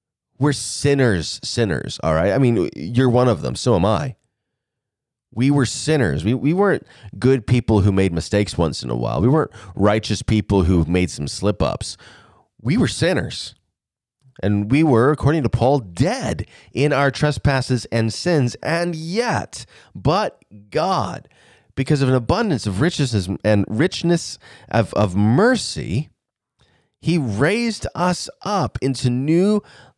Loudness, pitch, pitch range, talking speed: -19 LUFS, 125 Hz, 105-145 Hz, 145 wpm